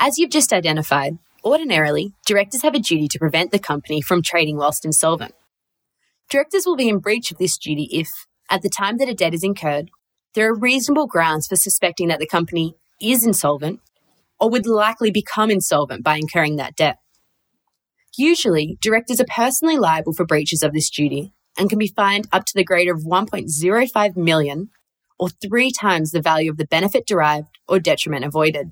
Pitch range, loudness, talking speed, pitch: 155-215 Hz, -18 LUFS, 180 wpm, 180 Hz